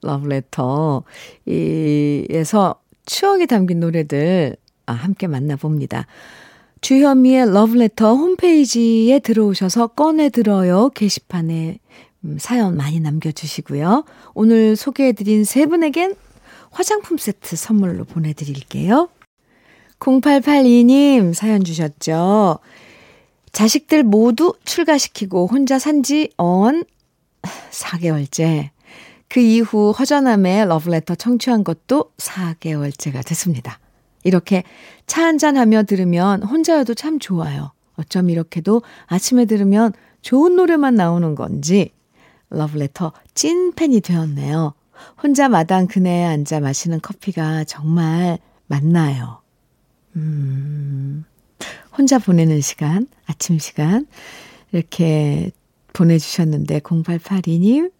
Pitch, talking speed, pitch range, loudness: 185 Hz, 235 characters per minute, 160-245 Hz, -16 LUFS